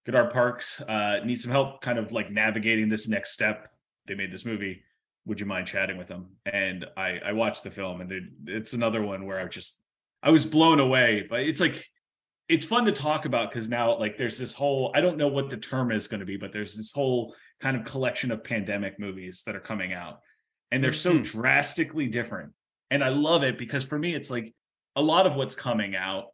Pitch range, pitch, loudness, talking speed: 100-135 Hz, 115 Hz, -27 LUFS, 225 wpm